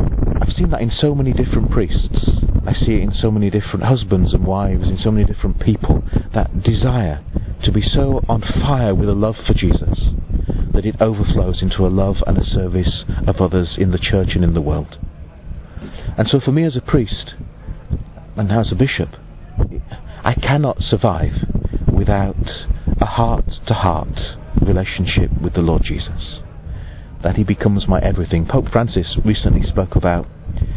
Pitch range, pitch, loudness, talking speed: 85-110 Hz, 95 Hz, -18 LUFS, 170 wpm